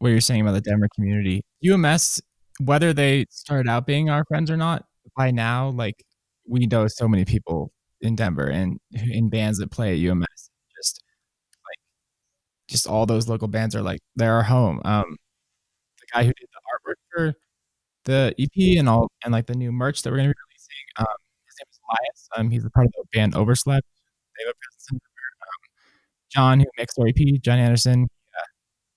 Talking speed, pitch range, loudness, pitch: 190 wpm, 110-135 Hz, -22 LUFS, 120 Hz